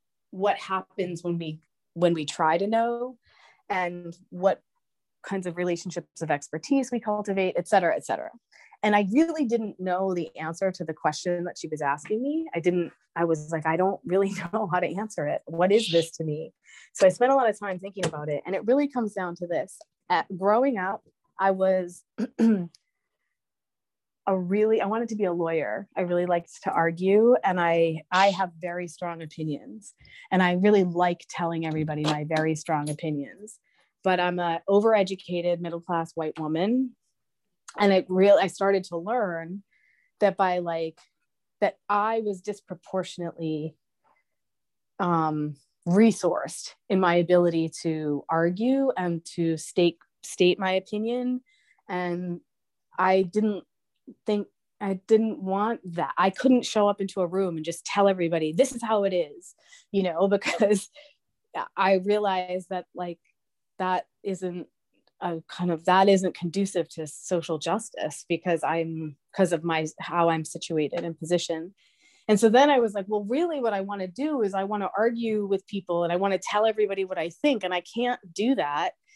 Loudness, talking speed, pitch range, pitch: -26 LUFS, 175 wpm, 170-210 Hz, 185 Hz